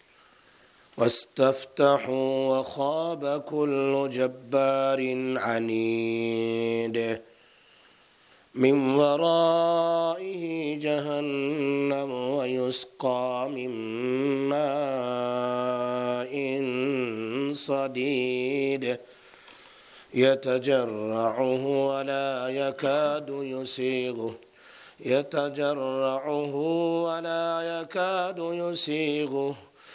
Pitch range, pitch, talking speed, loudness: 125-145 Hz, 135 Hz, 40 wpm, -27 LUFS